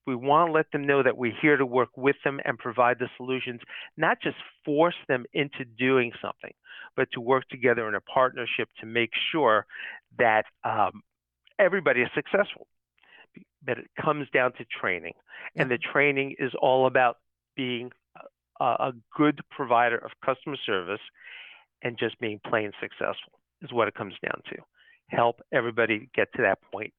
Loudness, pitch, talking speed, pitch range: -26 LUFS, 125 Hz, 170 wpm, 120-140 Hz